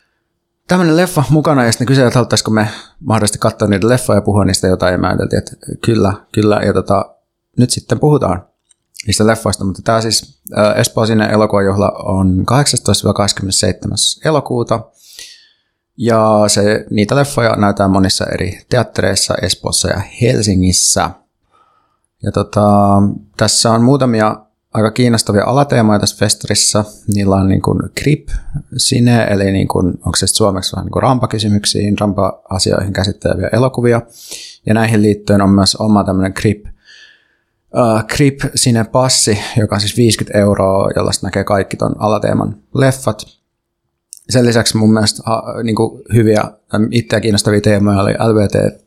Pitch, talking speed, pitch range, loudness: 105 Hz, 140 wpm, 100-120 Hz, -13 LUFS